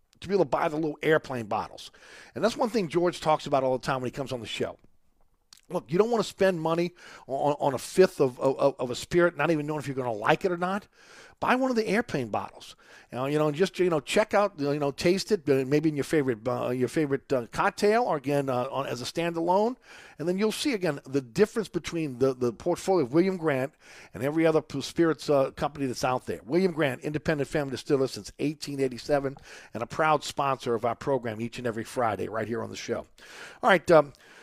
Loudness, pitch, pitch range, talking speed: -27 LUFS, 150 Hz, 135-175 Hz, 240 wpm